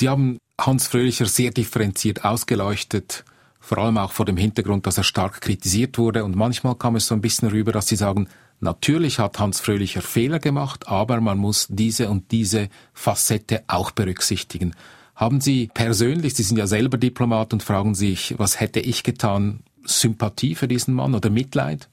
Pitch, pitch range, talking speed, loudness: 110 Hz, 105-125 Hz, 180 wpm, -21 LUFS